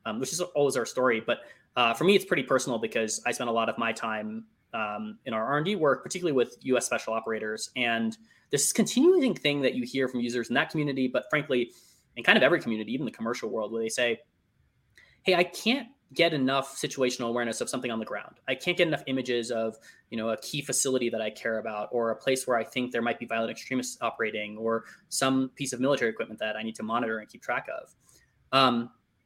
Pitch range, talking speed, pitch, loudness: 115-140 Hz, 235 wpm, 120 Hz, -28 LUFS